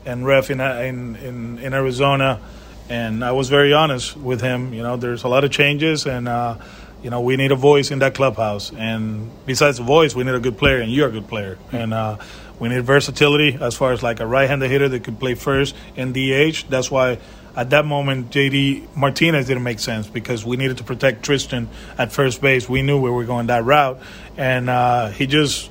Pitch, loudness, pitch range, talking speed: 130 Hz, -18 LUFS, 120-140 Hz, 220 wpm